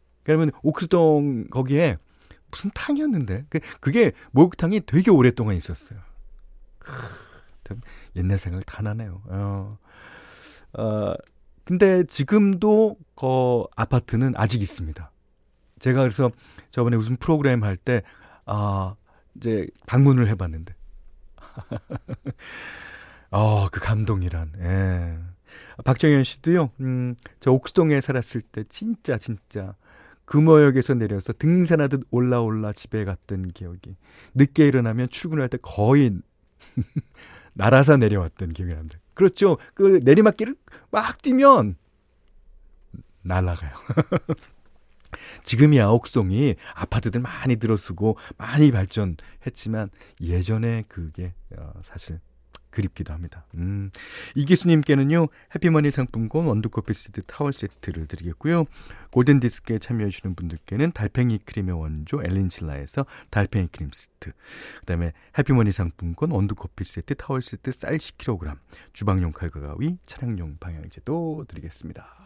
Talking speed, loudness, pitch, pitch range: 275 characters per minute, -22 LUFS, 110 Hz, 90-140 Hz